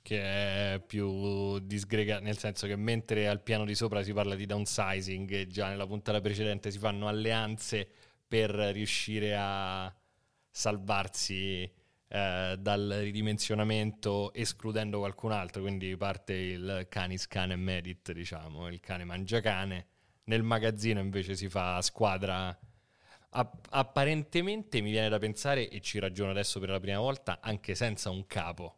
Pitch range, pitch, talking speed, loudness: 95-110 Hz, 100 Hz, 145 wpm, -33 LUFS